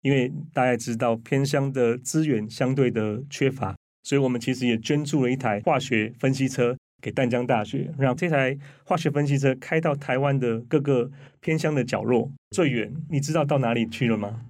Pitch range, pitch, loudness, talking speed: 120-140 Hz, 130 Hz, -25 LUFS, 285 characters per minute